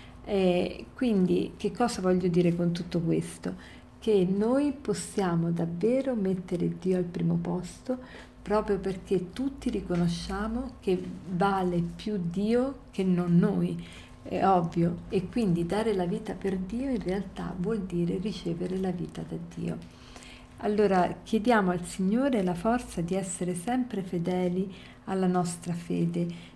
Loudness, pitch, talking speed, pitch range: -29 LUFS, 185 Hz, 135 wpm, 175-210 Hz